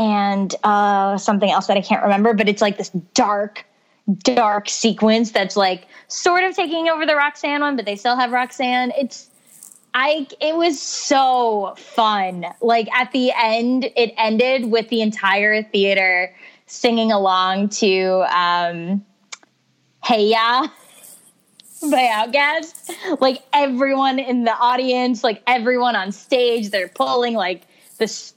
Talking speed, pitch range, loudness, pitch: 140 wpm, 205-260 Hz, -18 LUFS, 230 Hz